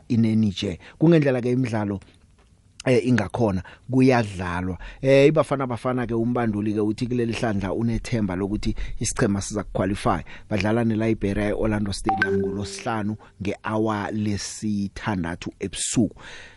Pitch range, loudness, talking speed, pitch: 100-120 Hz, -24 LUFS, 110 wpm, 105 Hz